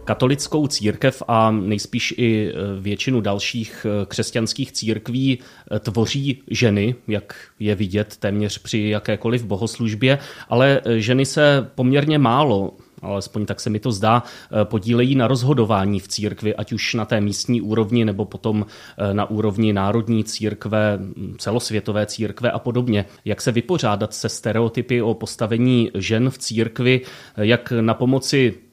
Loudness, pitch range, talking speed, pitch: -20 LUFS, 105-125 Hz, 130 wpm, 115 Hz